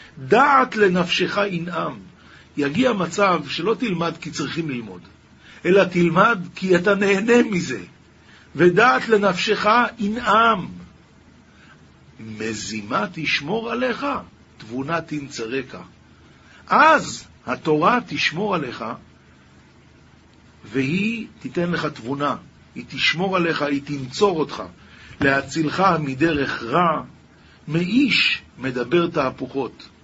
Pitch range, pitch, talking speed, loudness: 135-200 Hz, 165 Hz, 90 wpm, -20 LUFS